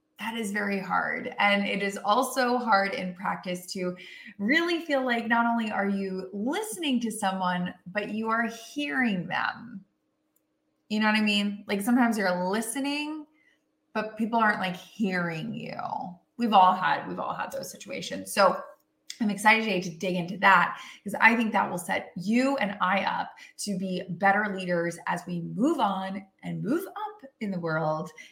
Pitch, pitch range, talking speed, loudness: 210 Hz, 185-245 Hz, 175 wpm, -27 LUFS